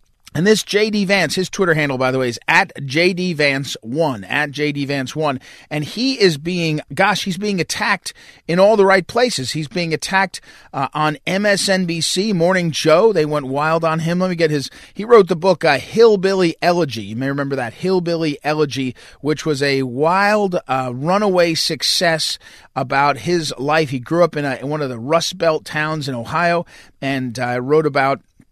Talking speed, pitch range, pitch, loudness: 185 wpm, 140-185 Hz, 160 Hz, -17 LUFS